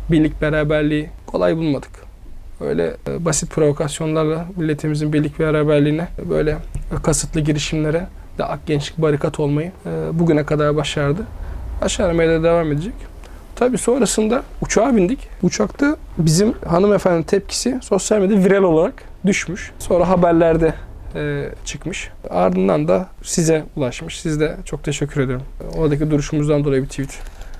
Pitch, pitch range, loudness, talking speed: 155 Hz, 145-170 Hz, -18 LUFS, 130 wpm